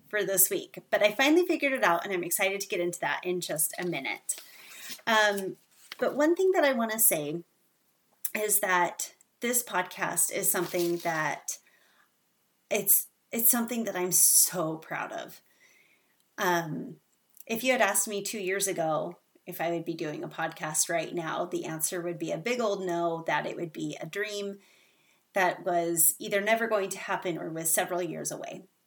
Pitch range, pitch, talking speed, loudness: 170-215 Hz, 185 Hz, 185 wpm, -27 LUFS